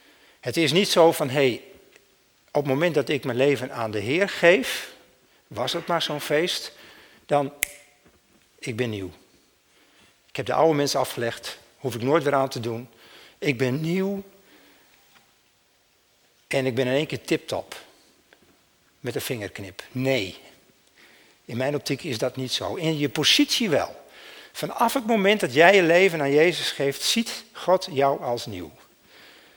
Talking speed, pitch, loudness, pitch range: 160 wpm, 140 Hz, -23 LUFS, 130-165 Hz